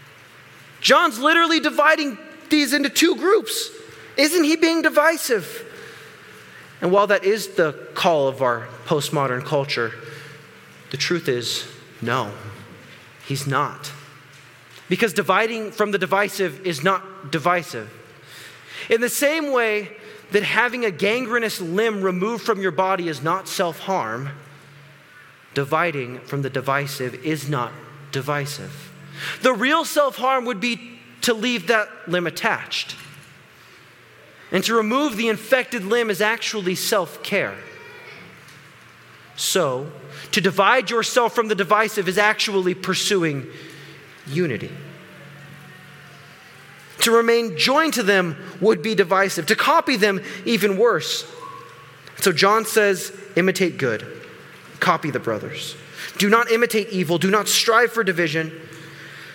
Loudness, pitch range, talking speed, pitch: -20 LUFS, 155-235 Hz, 120 wpm, 195 Hz